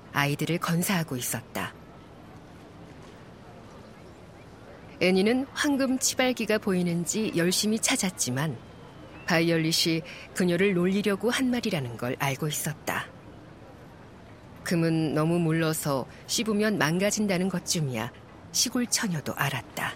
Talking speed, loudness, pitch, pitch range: 245 characters per minute, -27 LUFS, 170 Hz, 150-210 Hz